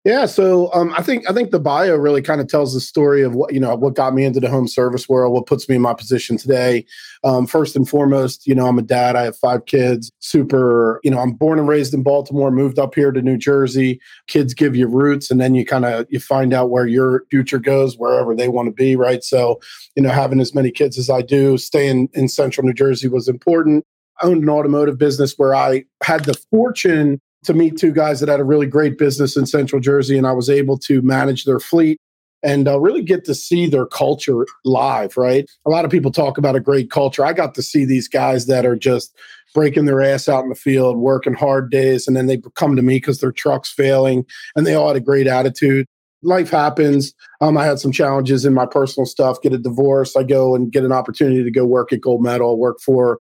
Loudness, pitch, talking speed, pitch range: -16 LUFS, 135 Hz, 240 wpm, 130-145 Hz